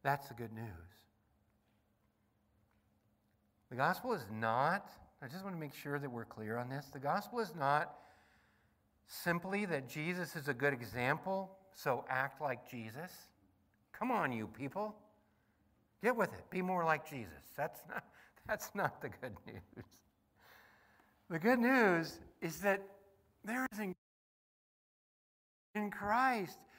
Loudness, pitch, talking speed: -38 LUFS, 145 Hz, 135 wpm